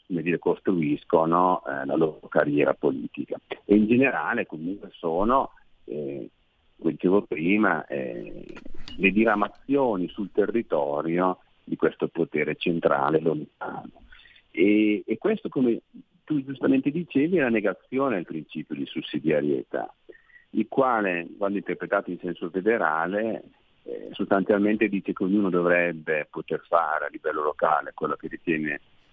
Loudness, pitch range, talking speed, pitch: -25 LUFS, 90-135 Hz, 125 wpm, 100 Hz